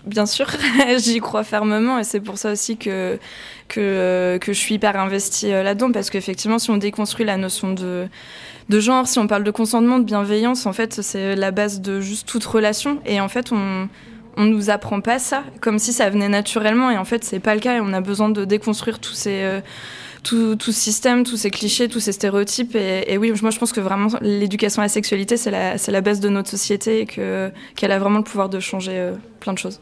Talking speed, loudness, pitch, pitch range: 230 wpm, -19 LUFS, 210 Hz, 200-225 Hz